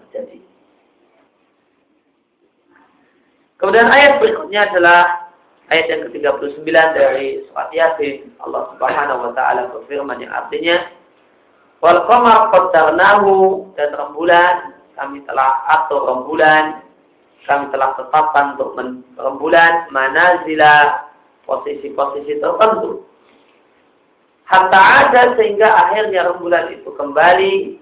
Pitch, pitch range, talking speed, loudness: 175 Hz, 145-215 Hz, 90 wpm, -13 LUFS